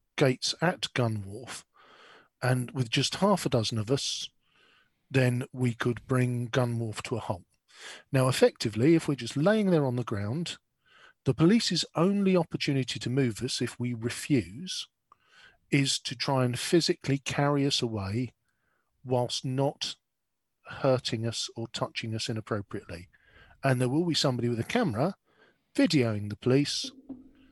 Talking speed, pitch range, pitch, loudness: 150 wpm, 120-150 Hz, 130 Hz, -28 LUFS